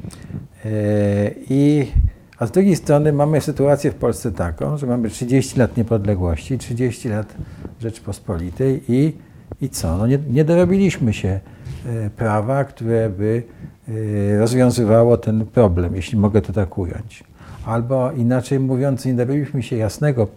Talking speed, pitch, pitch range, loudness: 130 wpm, 115 Hz, 105-135 Hz, -19 LUFS